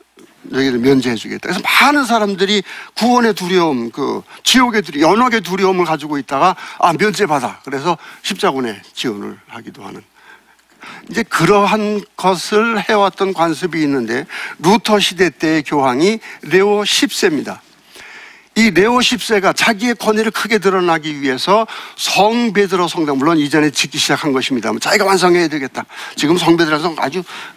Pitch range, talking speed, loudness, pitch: 155-215 Hz, 335 characters per minute, -14 LUFS, 190 Hz